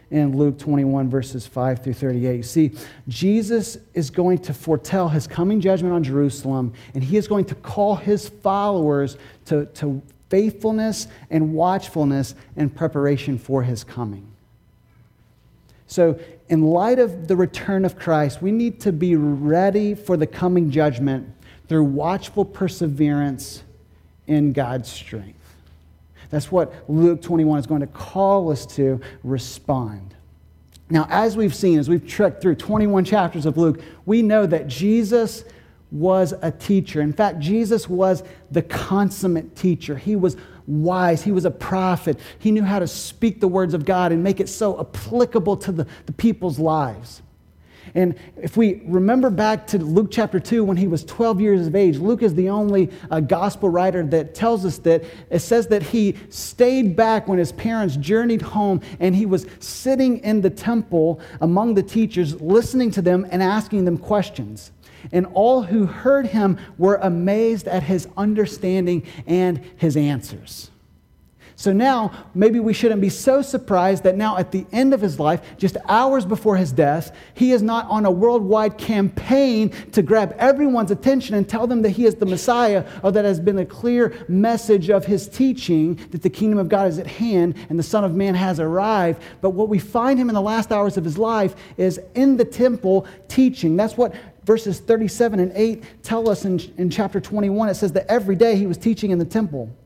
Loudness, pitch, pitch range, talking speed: -20 LUFS, 185 Hz, 155-210 Hz, 175 wpm